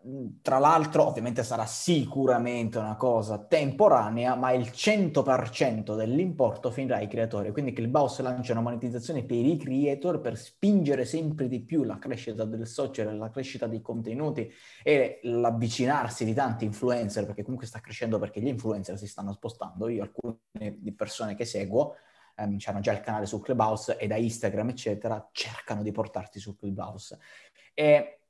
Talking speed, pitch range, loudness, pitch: 155 wpm, 110-130 Hz, -28 LUFS, 120 Hz